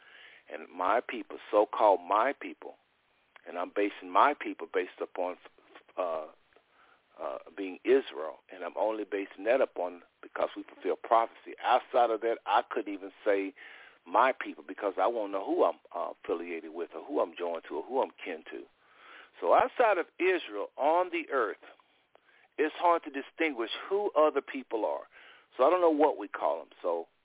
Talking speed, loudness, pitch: 175 wpm, -31 LUFS, 340 Hz